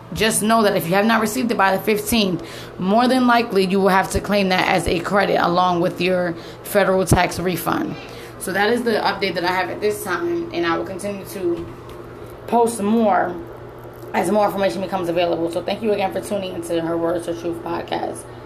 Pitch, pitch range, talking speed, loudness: 190 Hz, 175-210 Hz, 210 wpm, -19 LUFS